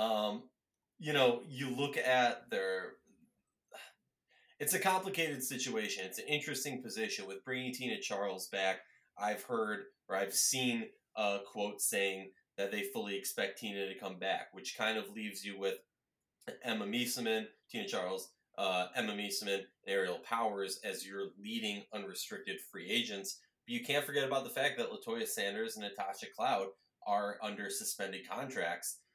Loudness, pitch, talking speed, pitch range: -37 LUFS, 110 Hz, 150 wpm, 100-145 Hz